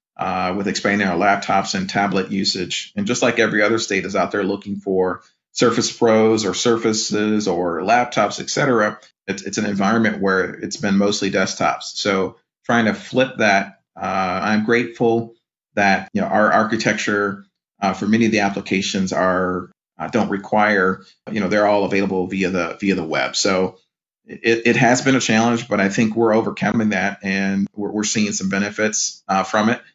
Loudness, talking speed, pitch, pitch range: -19 LUFS, 180 wpm, 100 Hz, 95-110 Hz